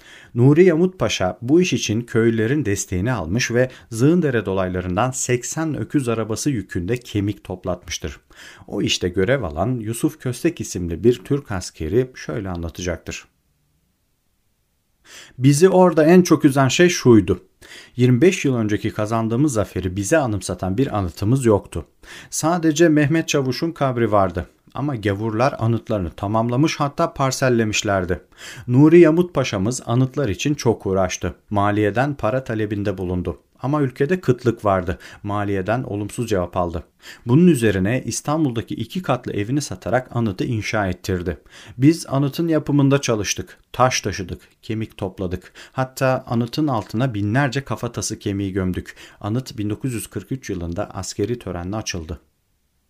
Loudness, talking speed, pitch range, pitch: -20 LUFS, 120 wpm, 95-135 Hz, 115 Hz